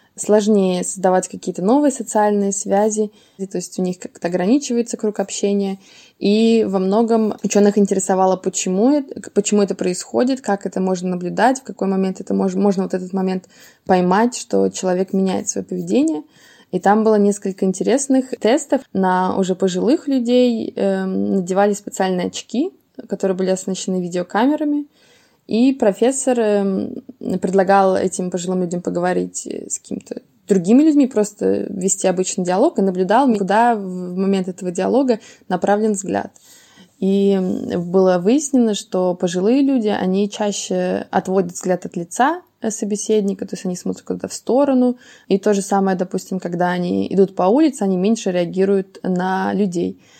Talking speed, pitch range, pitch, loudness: 140 wpm, 185-225 Hz, 195 Hz, -18 LUFS